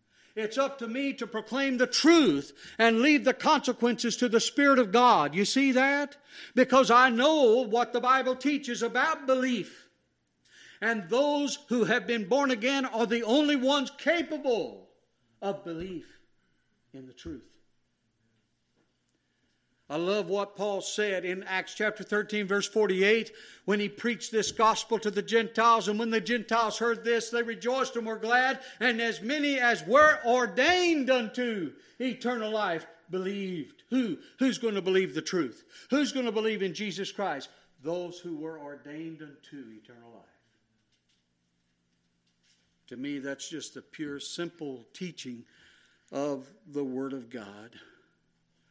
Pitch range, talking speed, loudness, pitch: 170-255 Hz, 150 wpm, -27 LUFS, 225 Hz